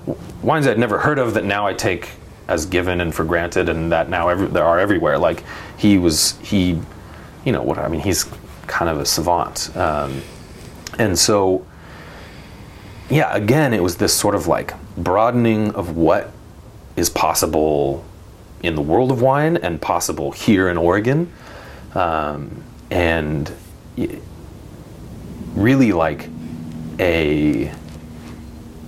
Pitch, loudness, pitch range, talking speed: 85 Hz, -18 LUFS, 80-100 Hz, 140 wpm